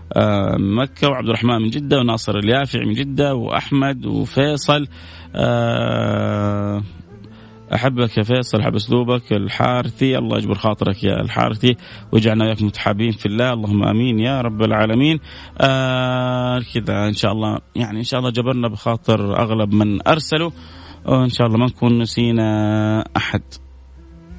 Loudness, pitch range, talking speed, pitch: -18 LUFS, 105-125 Hz, 130 wpm, 115 Hz